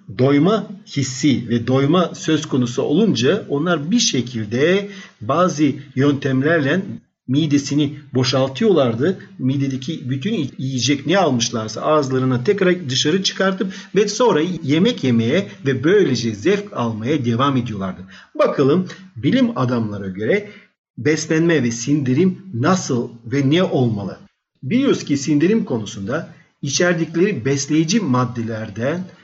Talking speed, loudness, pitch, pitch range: 105 wpm, -18 LUFS, 145 Hz, 125-175 Hz